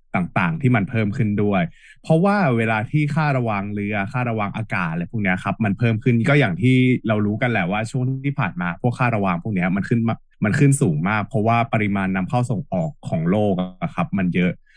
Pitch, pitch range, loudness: 115 Hz, 100-140 Hz, -20 LUFS